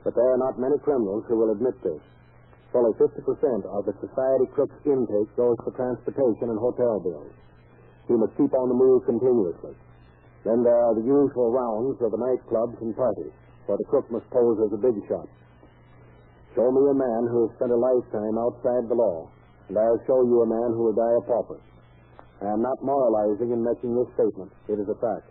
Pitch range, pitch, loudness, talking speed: 110-125 Hz, 120 Hz, -24 LUFS, 200 wpm